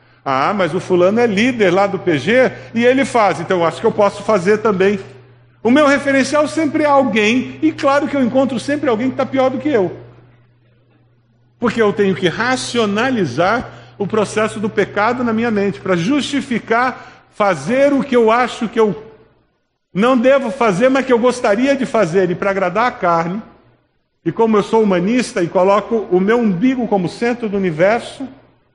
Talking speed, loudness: 185 wpm, -15 LUFS